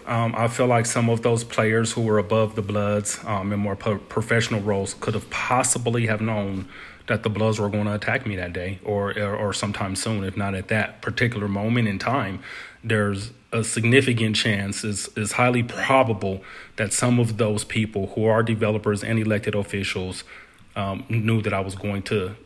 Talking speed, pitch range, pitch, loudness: 195 wpm, 100-115 Hz, 110 Hz, -23 LUFS